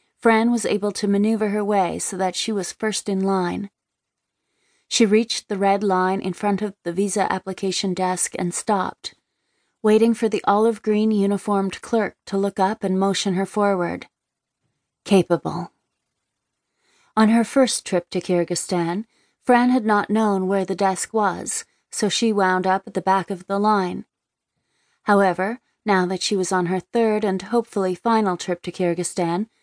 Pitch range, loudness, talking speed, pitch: 185-215 Hz, -21 LUFS, 165 wpm, 200 Hz